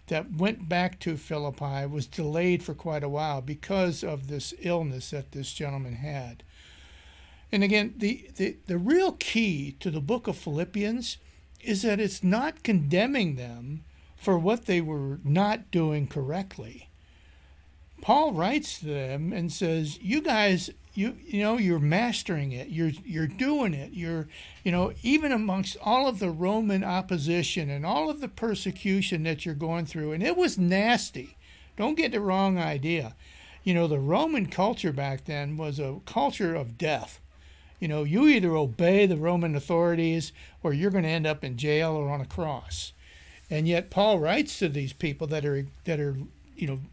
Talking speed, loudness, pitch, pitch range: 175 wpm, -28 LUFS, 165 Hz, 145-195 Hz